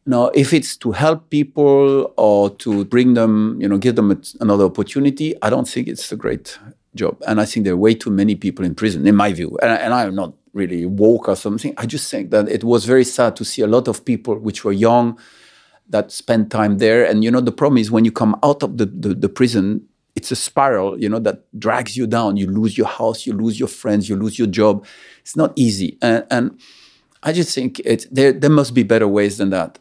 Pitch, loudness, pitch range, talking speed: 110 Hz, -17 LUFS, 100-125 Hz, 240 wpm